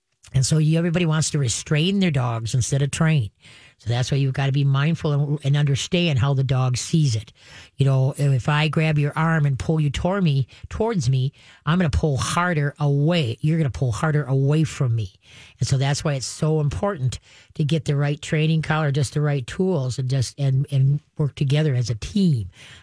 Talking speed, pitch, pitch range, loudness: 215 wpm, 145 Hz, 130-155 Hz, -22 LUFS